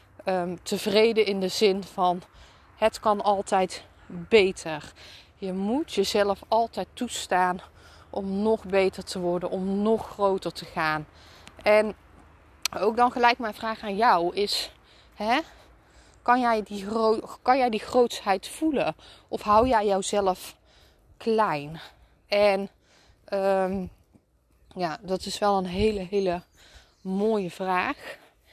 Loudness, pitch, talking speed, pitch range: -25 LUFS, 195 Hz, 125 wpm, 185-220 Hz